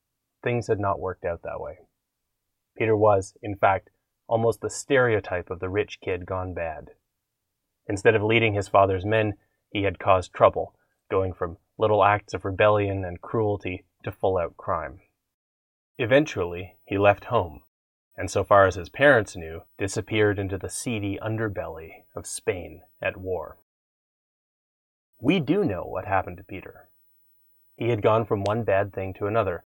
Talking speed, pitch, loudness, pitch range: 160 wpm, 100 Hz, -25 LUFS, 95-110 Hz